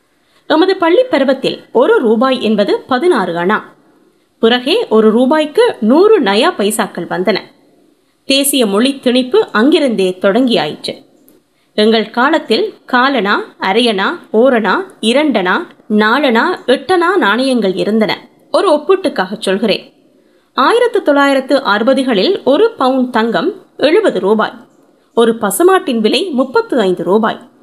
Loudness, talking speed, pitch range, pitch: -12 LUFS, 105 wpm, 220-330 Hz, 260 Hz